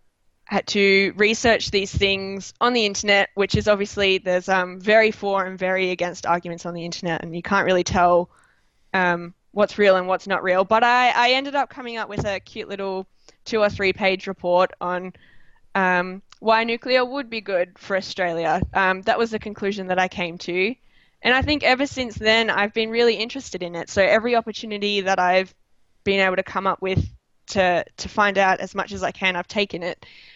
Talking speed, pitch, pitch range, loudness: 205 wpm, 195 Hz, 185-215 Hz, -21 LUFS